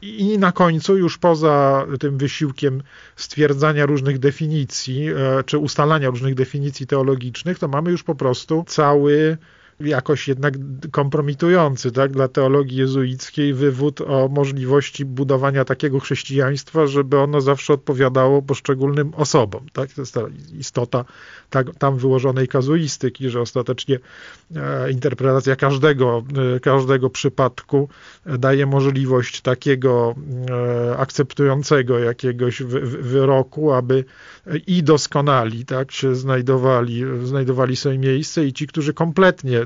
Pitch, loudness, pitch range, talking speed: 140 Hz, -19 LUFS, 130-145 Hz, 110 wpm